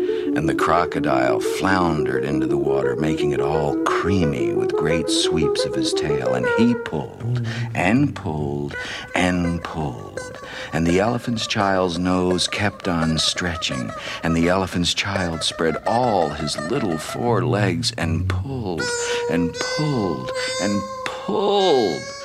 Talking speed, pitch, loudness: 130 wpm, 120 Hz, -21 LUFS